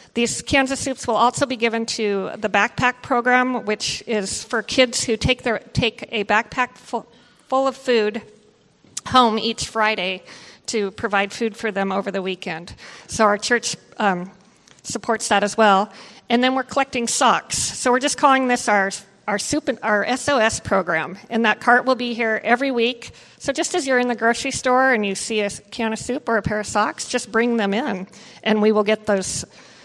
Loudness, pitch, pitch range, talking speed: -20 LUFS, 225 Hz, 210-250 Hz, 200 wpm